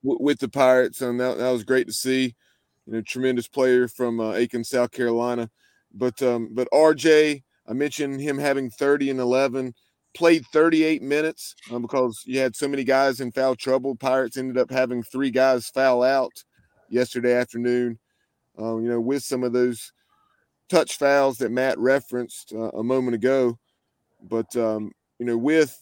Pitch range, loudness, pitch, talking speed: 120-135 Hz, -23 LUFS, 130 Hz, 170 wpm